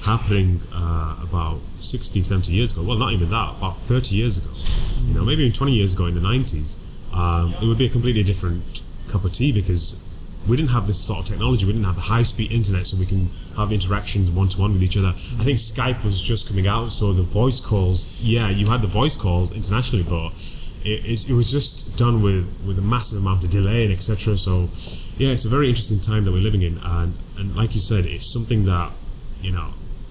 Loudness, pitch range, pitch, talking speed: -20 LUFS, 90-115 Hz, 100 Hz, 225 wpm